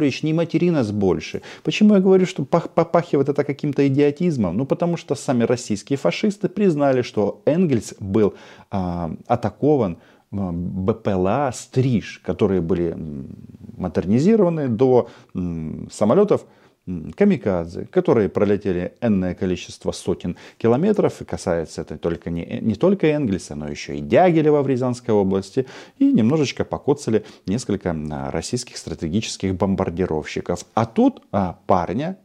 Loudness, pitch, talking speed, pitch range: -21 LUFS, 115 Hz, 125 wpm, 90-150 Hz